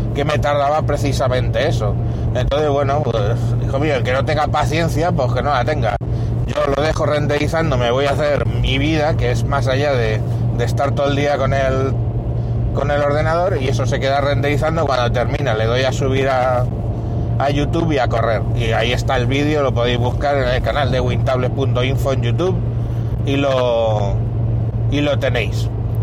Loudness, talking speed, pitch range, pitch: -17 LUFS, 190 wpm, 115-140 Hz, 125 Hz